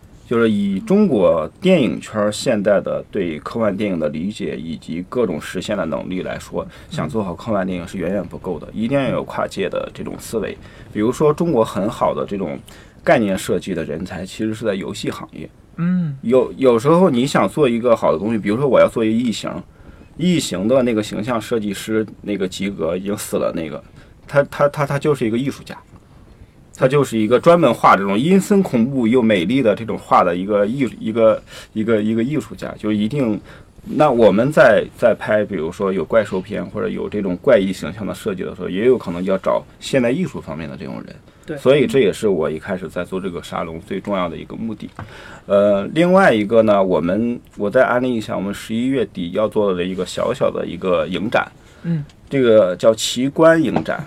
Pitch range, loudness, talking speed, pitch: 105-145 Hz, -18 LUFS, 310 characters per minute, 115 Hz